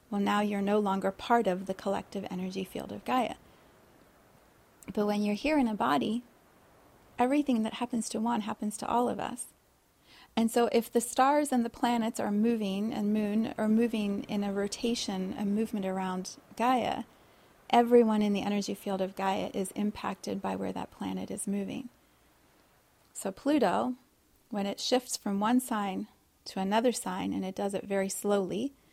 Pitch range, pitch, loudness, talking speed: 195-235 Hz, 210 Hz, -31 LUFS, 170 wpm